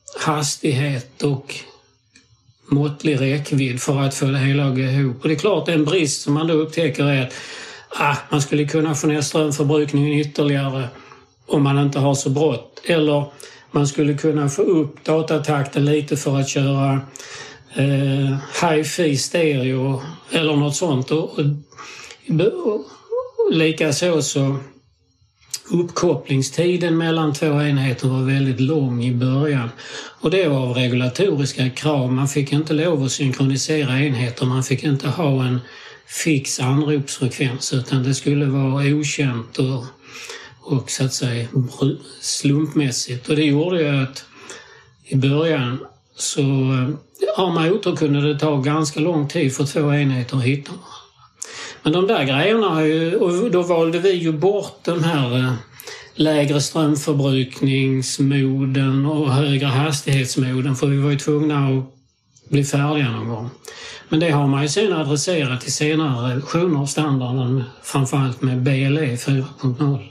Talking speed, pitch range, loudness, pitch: 135 wpm, 135-155 Hz, -19 LUFS, 145 Hz